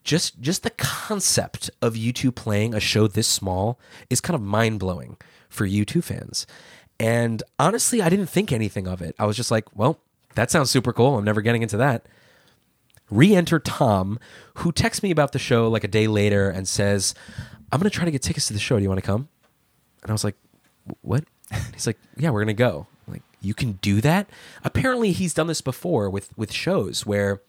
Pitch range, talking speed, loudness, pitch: 105-150 Hz, 210 wpm, -22 LUFS, 115 Hz